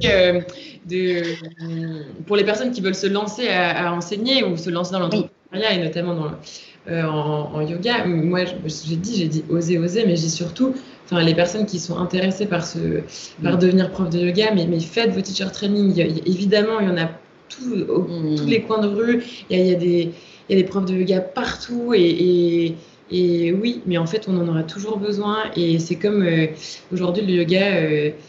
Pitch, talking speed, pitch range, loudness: 180 Hz, 215 wpm, 170-205 Hz, -20 LUFS